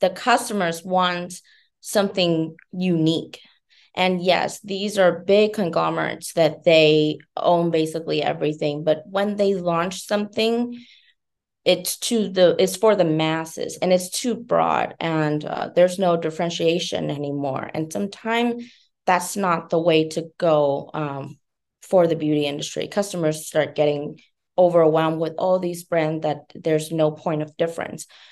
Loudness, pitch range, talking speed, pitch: -21 LUFS, 155-185 Hz, 140 wpm, 170 Hz